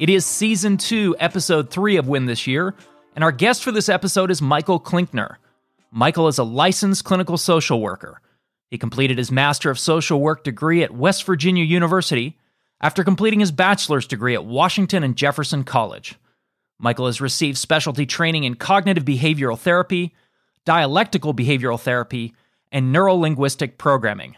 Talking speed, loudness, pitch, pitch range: 155 wpm, -19 LUFS, 160 Hz, 135-185 Hz